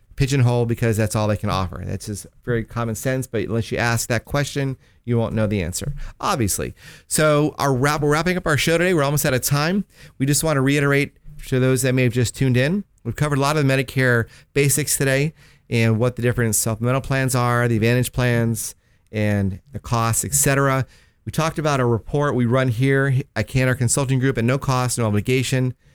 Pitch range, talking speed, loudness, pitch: 115-140 Hz, 210 wpm, -20 LUFS, 130 Hz